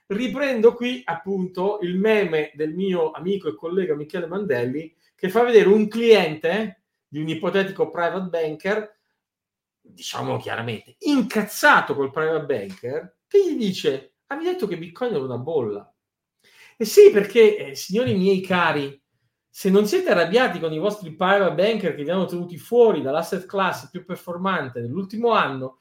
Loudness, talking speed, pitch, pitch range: -21 LUFS, 150 wpm, 195 Hz, 165-220 Hz